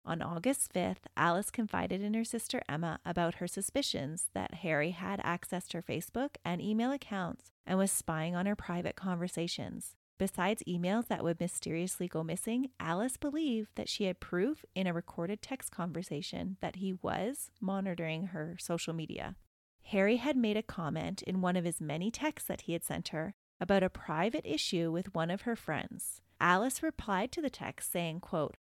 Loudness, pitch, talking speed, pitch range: -35 LUFS, 180 Hz, 180 wpm, 170-210 Hz